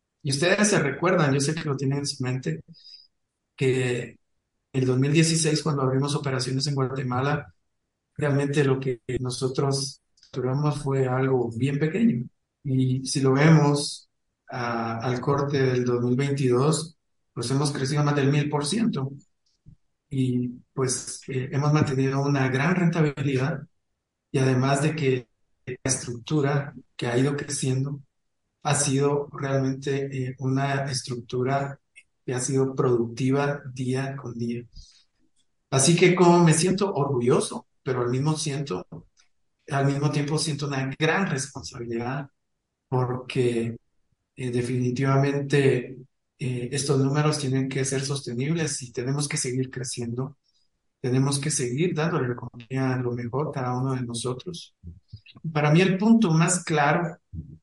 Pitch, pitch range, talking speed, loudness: 135 Hz, 125-145 Hz, 135 wpm, -25 LUFS